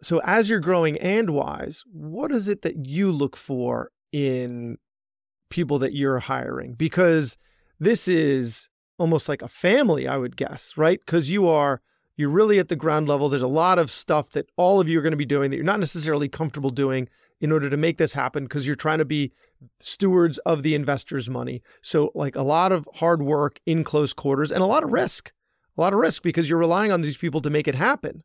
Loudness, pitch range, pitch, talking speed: -23 LUFS, 140-170 Hz, 155 Hz, 220 wpm